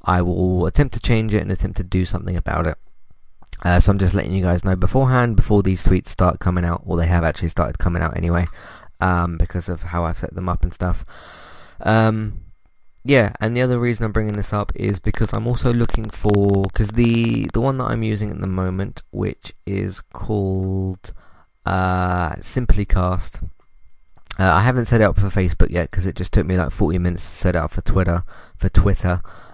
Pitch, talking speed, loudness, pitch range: 95 Hz, 210 wpm, -20 LUFS, 90-105 Hz